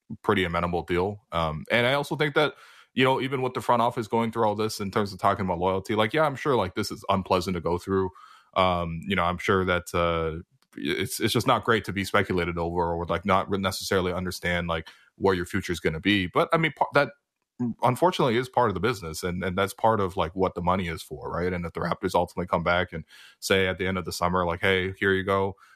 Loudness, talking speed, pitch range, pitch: -26 LUFS, 255 wpm, 90-110 Hz, 95 Hz